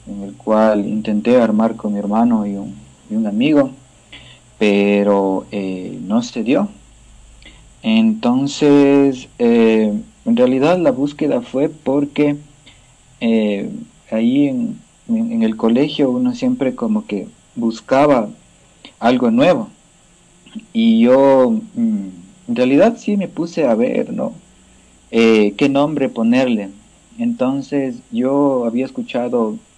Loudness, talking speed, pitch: -16 LUFS, 115 wpm, 145 Hz